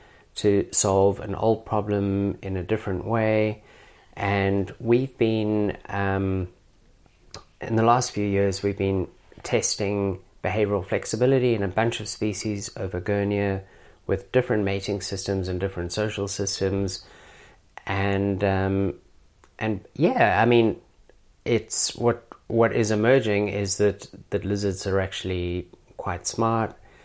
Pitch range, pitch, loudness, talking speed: 95-110 Hz, 100 Hz, -25 LUFS, 125 wpm